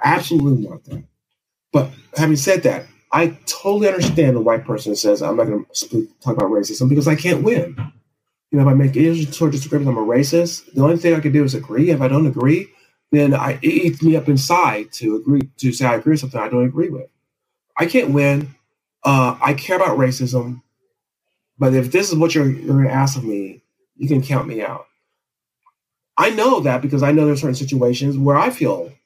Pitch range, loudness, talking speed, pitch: 130-165 Hz, -17 LUFS, 220 wpm, 145 Hz